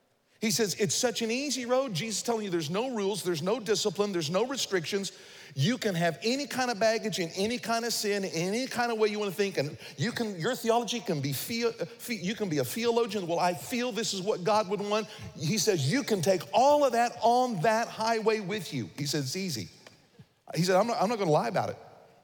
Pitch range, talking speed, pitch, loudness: 185-235 Hz, 245 wpm, 215 Hz, -29 LUFS